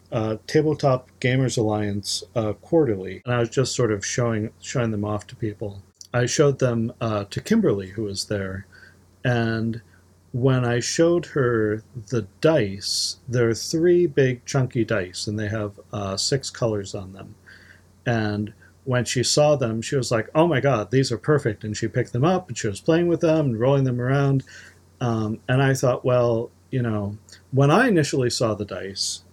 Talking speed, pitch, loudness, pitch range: 180 wpm, 115 Hz, -23 LUFS, 105-130 Hz